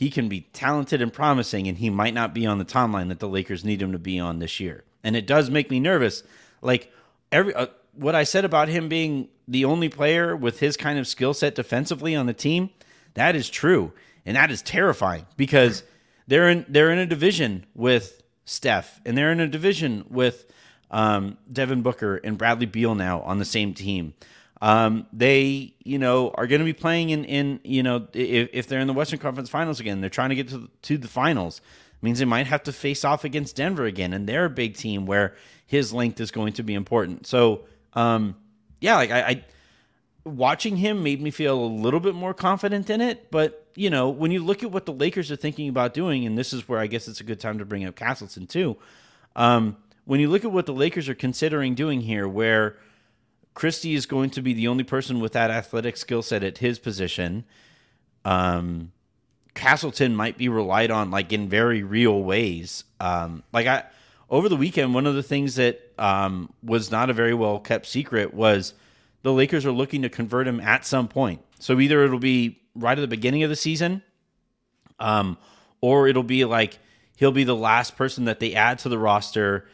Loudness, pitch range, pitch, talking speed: -23 LUFS, 110-145 Hz, 125 Hz, 215 wpm